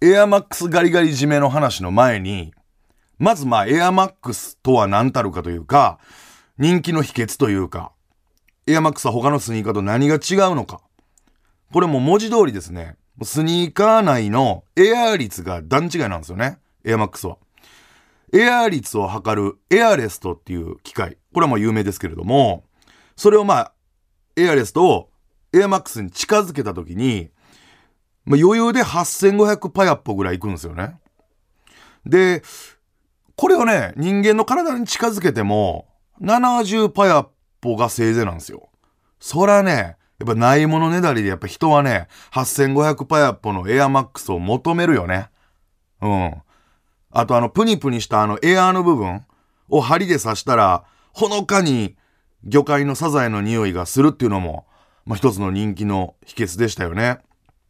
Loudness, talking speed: -18 LUFS, 320 characters per minute